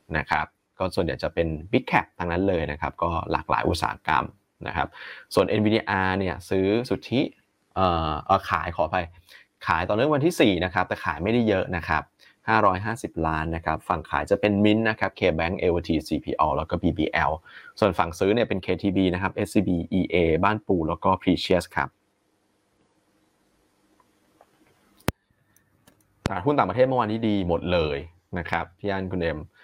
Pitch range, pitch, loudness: 85-105 Hz, 95 Hz, -25 LUFS